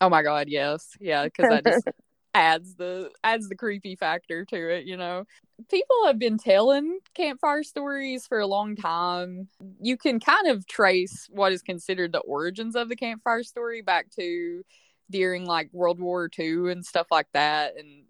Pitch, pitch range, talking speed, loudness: 190 Hz, 175-240 Hz, 180 wpm, -25 LUFS